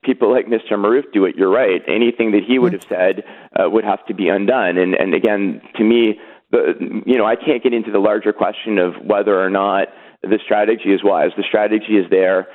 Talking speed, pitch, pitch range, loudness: 225 wpm, 110 Hz, 95-115 Hz, -16 LUFS